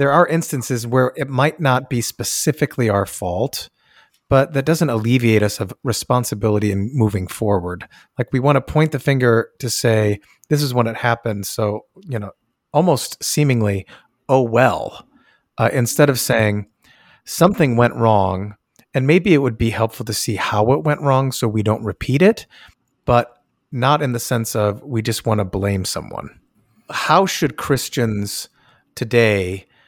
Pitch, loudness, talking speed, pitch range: 120 Hz, -18 LUFS, 165 wpm, 110-140 Hz